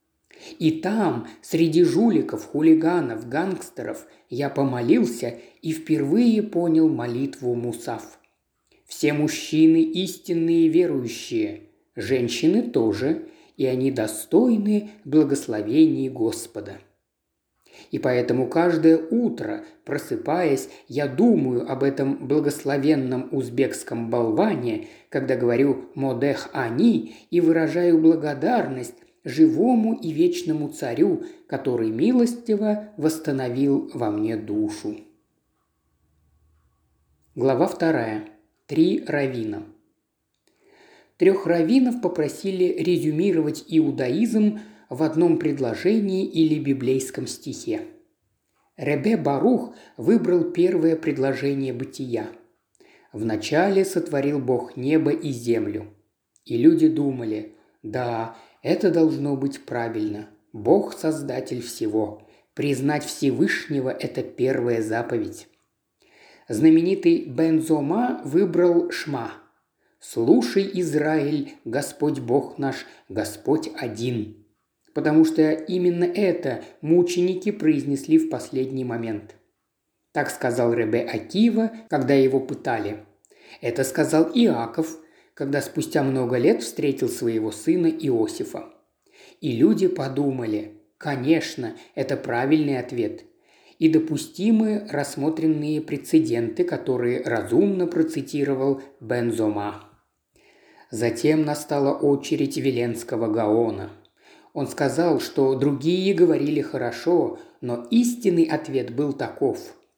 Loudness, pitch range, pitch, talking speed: -23 LUFS, 130-190 Hz, 155 Hz, 90 wpm